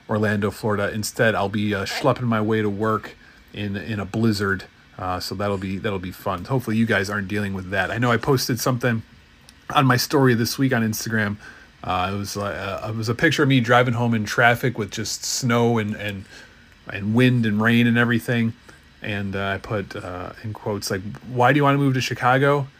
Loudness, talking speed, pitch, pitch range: -22 LUFS, 220 wpm, 110 Hz, 100-125 Hz